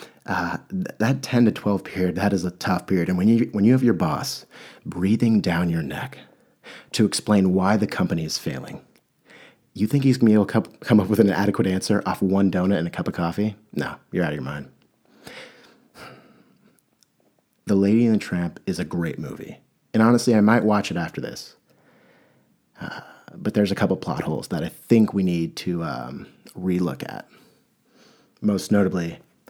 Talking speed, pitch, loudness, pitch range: 185 wpm, 100 Hz, -22 LUFS, 90-110 Hz